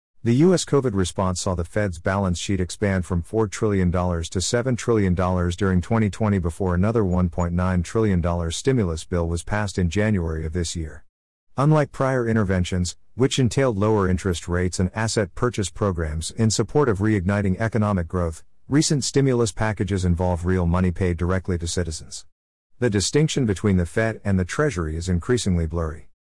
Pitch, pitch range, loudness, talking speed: 95 Hz, 90-110 Hz, -22 LUFS, 160 wpm